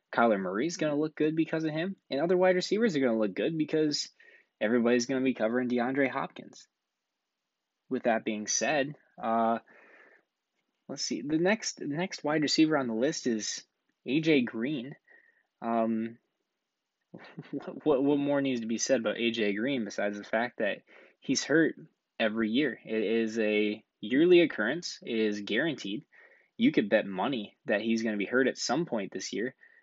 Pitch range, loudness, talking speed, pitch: 115-155 Hz, -29 LUFS, 175 wpm, 130 Hz